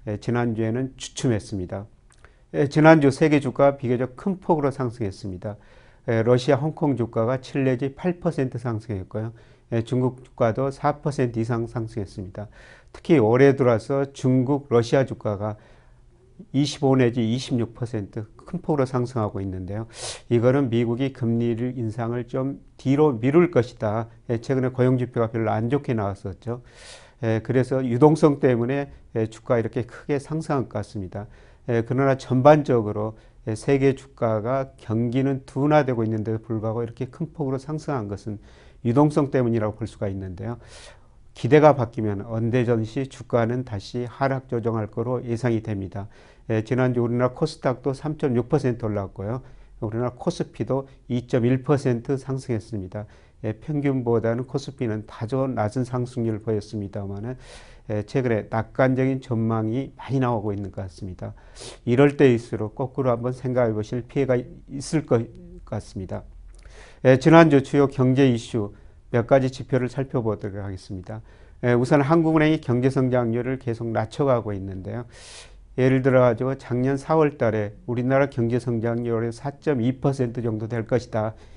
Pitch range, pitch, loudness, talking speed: 110-135 Hz, 120 Hz, -23 LUFS, 305 characters per minute